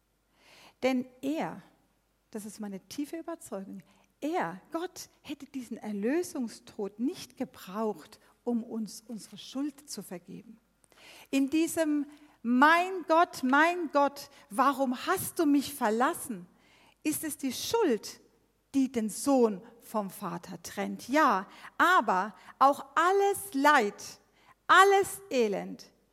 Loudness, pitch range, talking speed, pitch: -29 LUFS, 215-305 Hz, 110 wpm, 265 Hz